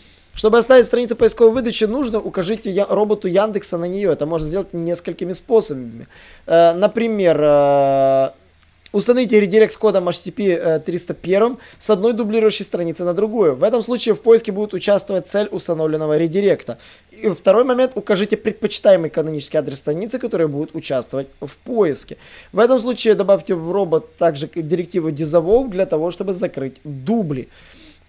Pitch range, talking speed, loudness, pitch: 160-215 Hz, 145 wpm, -17 LUFS, 190 Hz